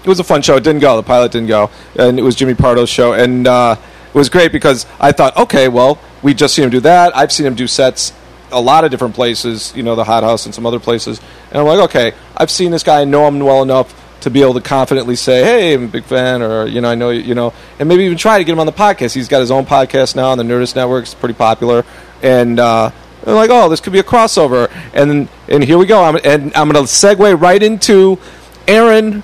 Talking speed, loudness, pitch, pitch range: 265 wpm, -10 LUFS, 130 Hz, 120-160 Hz